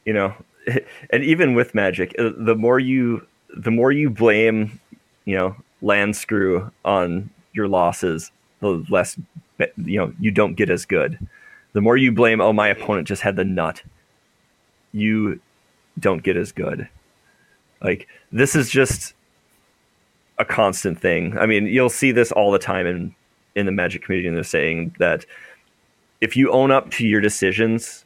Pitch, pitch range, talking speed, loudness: 110 Hz, 100-120 Hz, 160 wpm, -19 LUFS